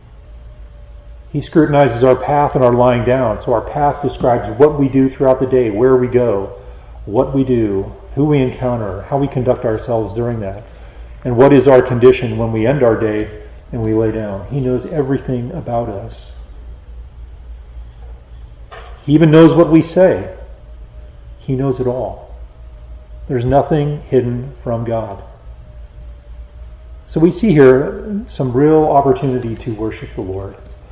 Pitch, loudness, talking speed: 120 Hz, -14 LUFS, 150 wpm